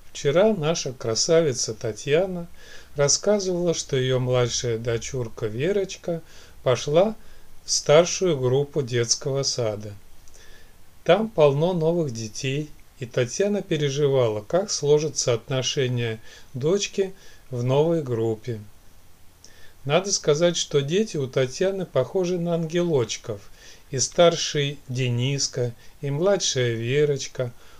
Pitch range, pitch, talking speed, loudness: 120-170 Hz, 140 Hz, 95 wpm, -23 LUFS